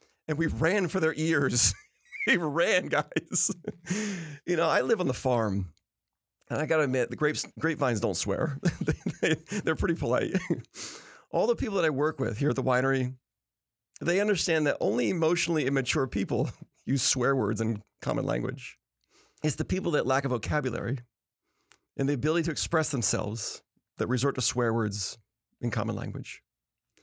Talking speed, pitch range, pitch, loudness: 165 wpm, 120-160 Hz, 135 Hz, -28 LUFS